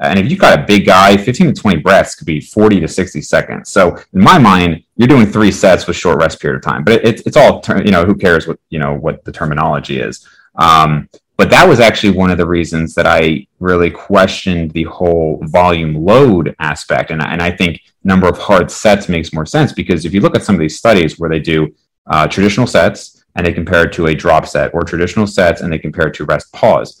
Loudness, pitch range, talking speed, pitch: -11 LUFS, 80-95 Hz, 245 wpm, 85 Hz